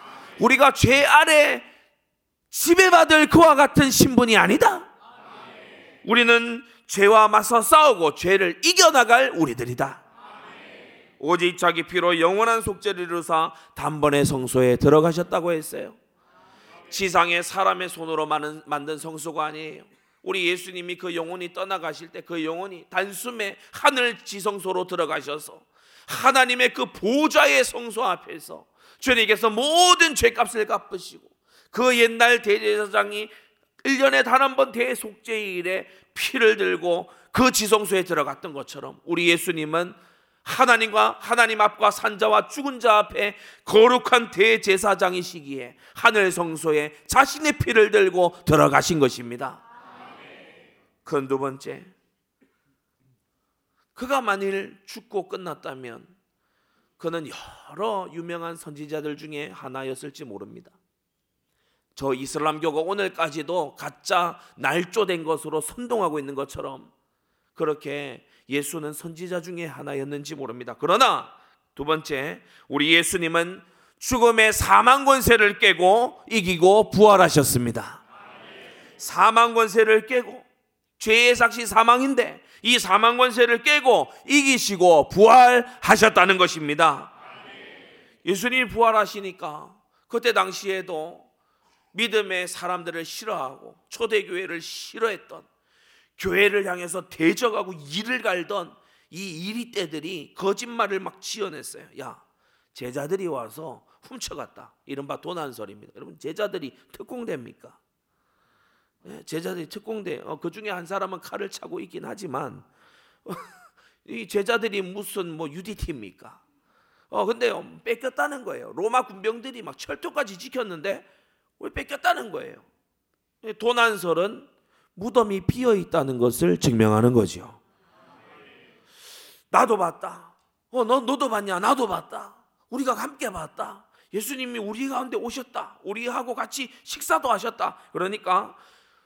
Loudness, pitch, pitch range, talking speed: -21 LUFS, 205 Hz, 170-245 Hz, 270 characters per minute